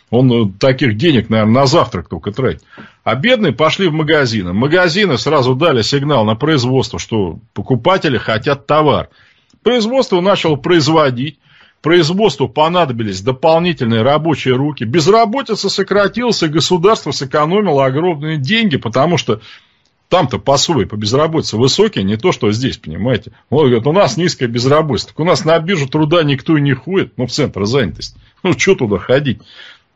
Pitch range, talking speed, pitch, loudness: 125-175 Hz, 150 wpm, 150 Hz, -13 LUFS